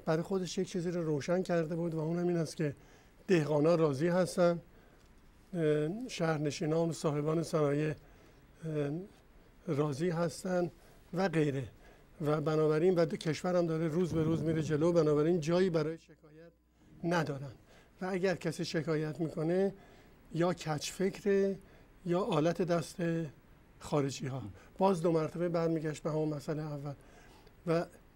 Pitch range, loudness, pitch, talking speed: 150-175 Hz, -33 LUFS, 165 Hz, 130 wpm